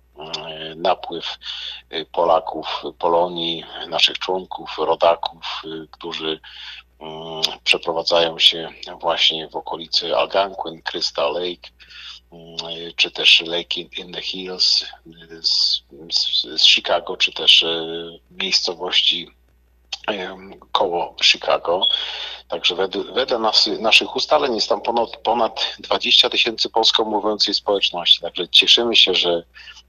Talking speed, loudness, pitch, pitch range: 90 wpm, -17 LUFS, 85 Hz, 80-85 Hz